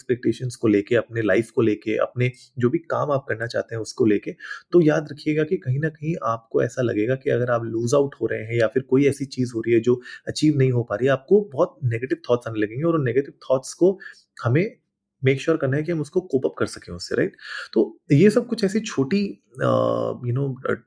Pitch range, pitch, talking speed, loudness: 115-155 Hz, 130 Hz, 245 wpm, -22 LUFS